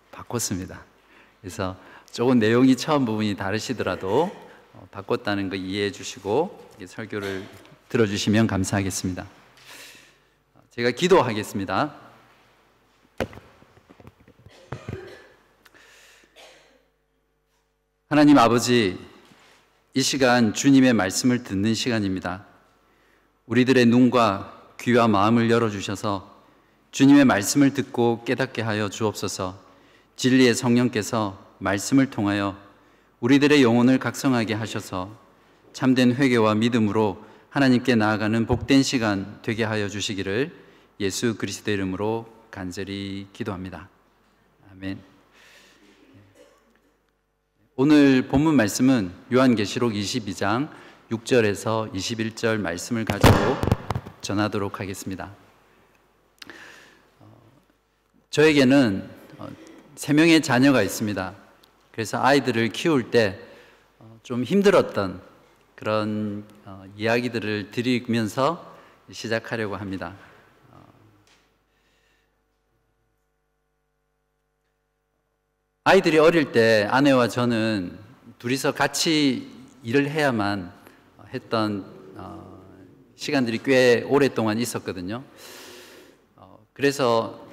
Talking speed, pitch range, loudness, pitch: 215 characters per minute, 100-130 Hz, -22 LUFS, 115 Hz